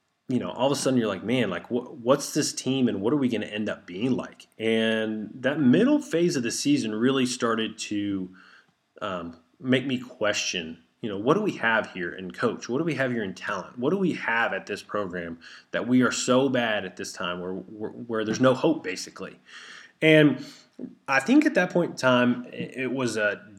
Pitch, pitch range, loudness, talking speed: 125 Hz, 105-135 Hz, -25 LUFS, 225 wpm